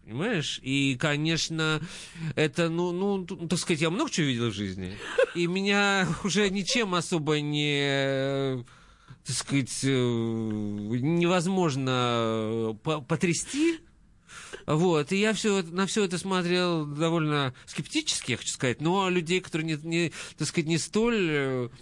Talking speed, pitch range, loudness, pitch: 125 wpm, 135-185 Hz, -27 LUFS, 160 Hz